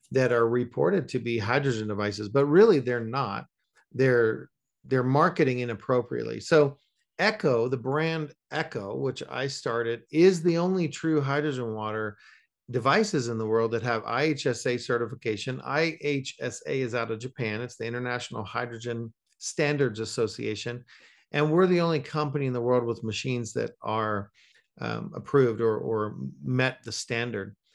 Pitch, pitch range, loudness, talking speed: 125 Hz, 115-140 Hz, -27 LUFS, 145 wpm